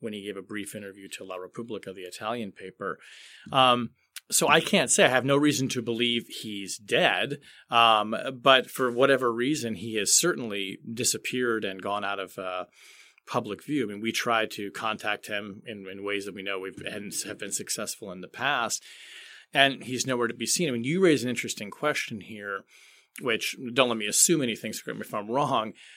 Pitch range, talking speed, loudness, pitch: 100-130 Hz, 195 wpm, -26 LUFS, 115 Hz